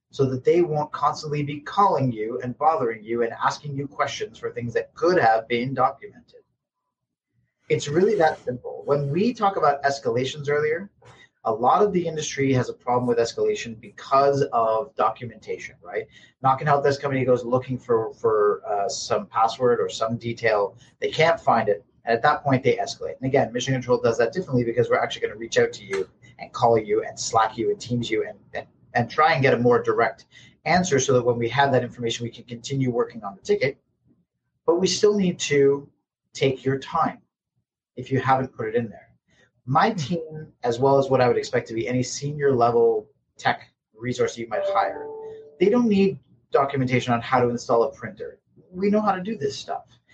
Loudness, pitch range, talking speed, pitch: -23 LUFS, 125-205 Hz, 205 wpm, 140 Hz